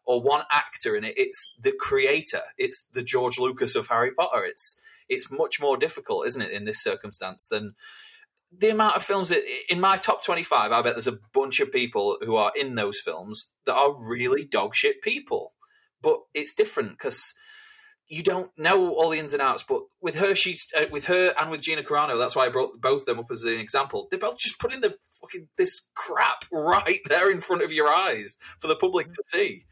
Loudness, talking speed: -24 LUFS, 210 wpm